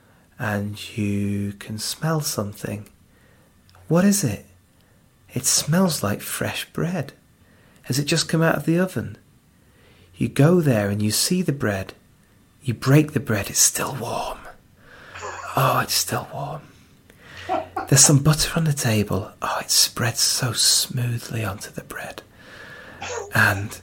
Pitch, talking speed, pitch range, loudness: 115 Hz, 140 wpm, 100-150 Hz, -21 LUFS